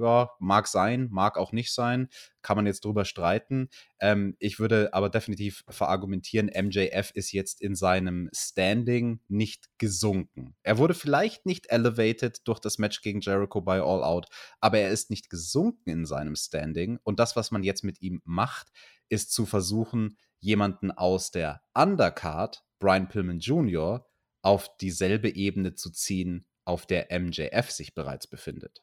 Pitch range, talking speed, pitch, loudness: 95-110 Hz, 155 wpm, 100 Hz, -28 LUFS